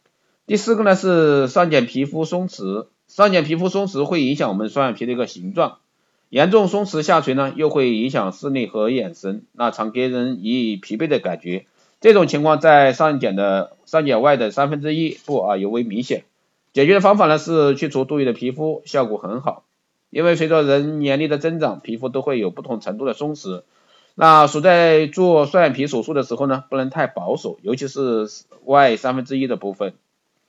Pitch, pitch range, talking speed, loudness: 140 Hz, 125-160 Hz, 290 characters per minute, -18 LUFS